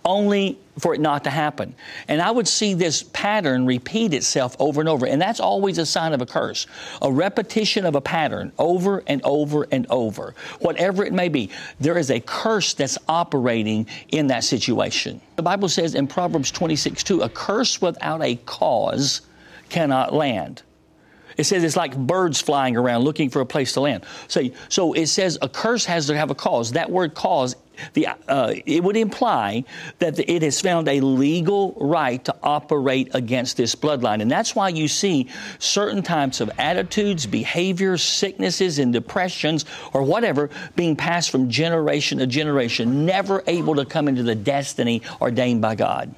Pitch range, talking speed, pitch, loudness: 135-185 Hz, 180 wpm, 155 Hz, -21 LUFS